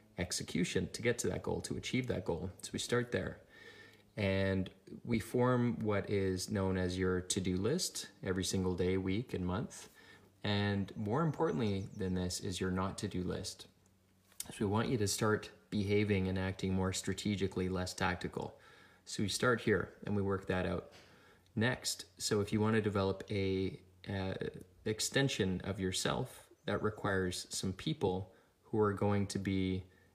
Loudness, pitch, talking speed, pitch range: -36 LUFS, 95 Hz, 165 wpm, 95-105 Hz